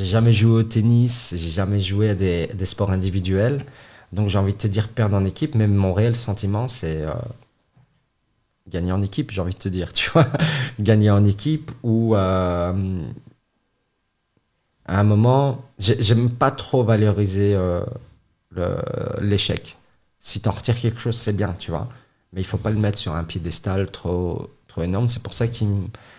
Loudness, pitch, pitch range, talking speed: -21 LUFS, 105 Hz, 95-120 Hz, 185 wpm